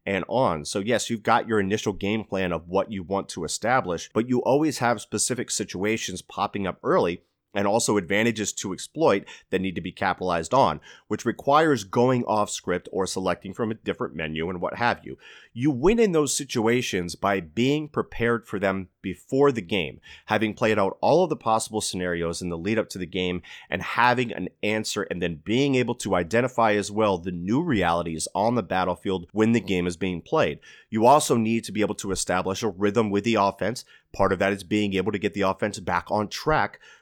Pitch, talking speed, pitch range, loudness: 105 Hz, 210 wpm, 95-115 Hz, -25 LUFS